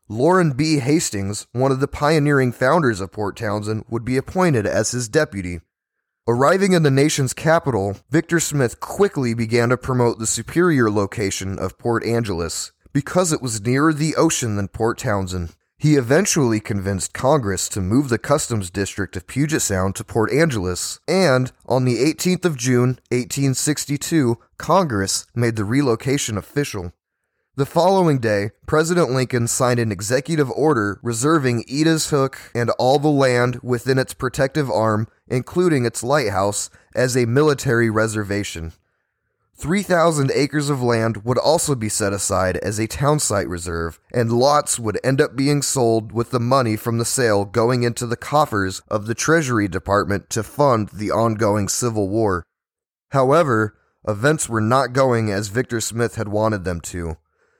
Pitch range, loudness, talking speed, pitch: 105-145 Hz, -19 LUFS, 155 wpm, 120 Hz